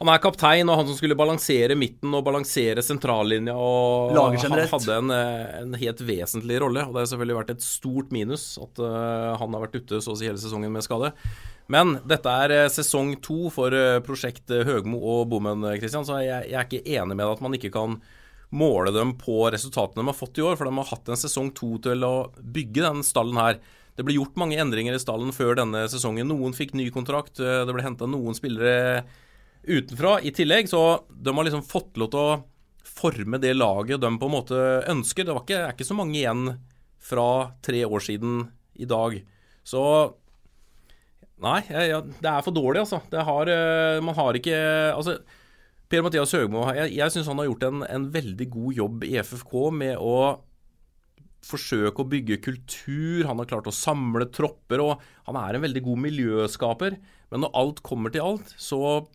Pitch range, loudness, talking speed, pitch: 115-150 Hz, -25 LUFS, 195 wpm, 130 Hz